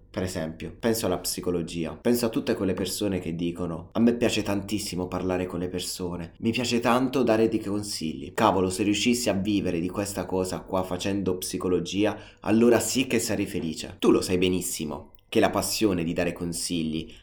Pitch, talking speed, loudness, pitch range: 95 Hz, 180 wpm, -26 LUFS, 90-105 Hz